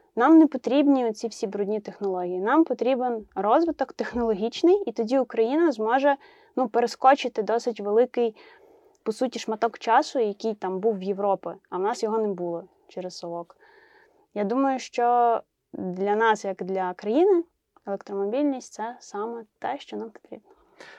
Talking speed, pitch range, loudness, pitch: 145 wpm, 205-270 Hz, -25 LUFS, 230 Hz